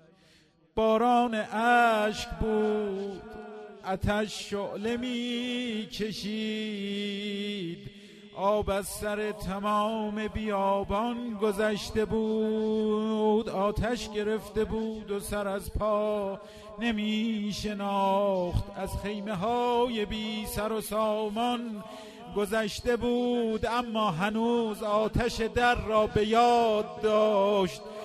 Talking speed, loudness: 85 wpm, -29 LUFS